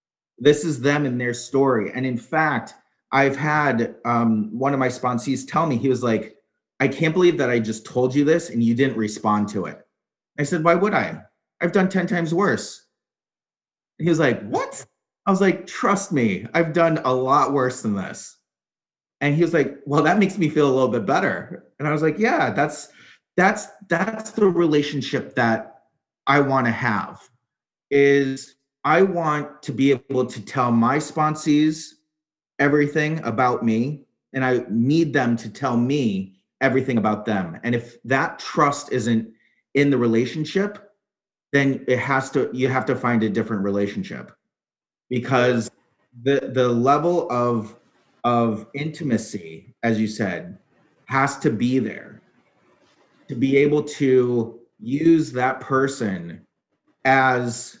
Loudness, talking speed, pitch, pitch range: -21 LUFS, 160 wpm, 135 Hz, 120-155 Hz